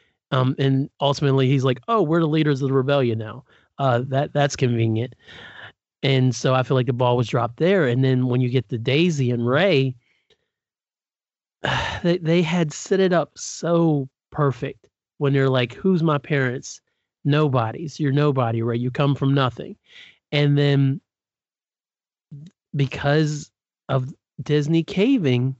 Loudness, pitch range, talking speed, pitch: -21 LUFS, 130-150 Hz, 150 wpm, 140 Hz